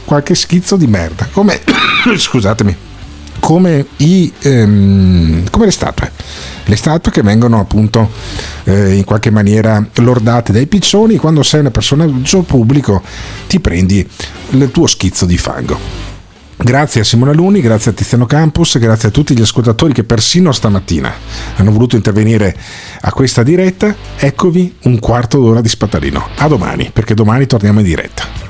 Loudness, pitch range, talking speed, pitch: -10 LUFS, 100-140 Hz, 150 wpm, 115 Hz